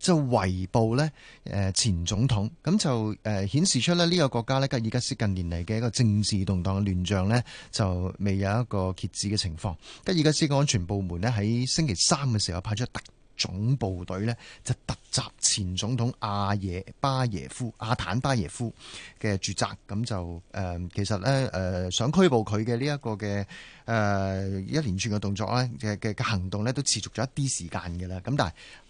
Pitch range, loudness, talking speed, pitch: 95-125 Hz, -27 LUFS, 270 characters per minute, 110 Hz